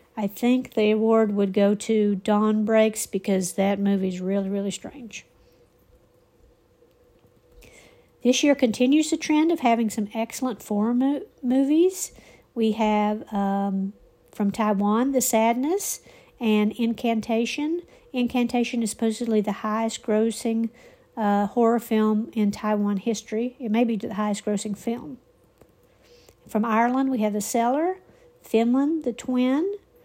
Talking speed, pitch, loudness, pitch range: 130 wpm, 225 Hz, -24 LUFS, 210-250 Hz